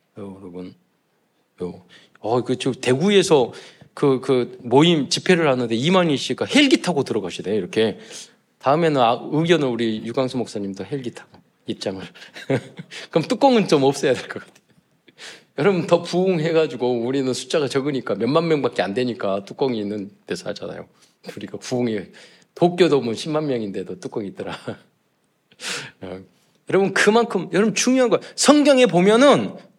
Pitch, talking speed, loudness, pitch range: 135 Hz, 315 characters per minute, -20 LUFS, 115-175 Hz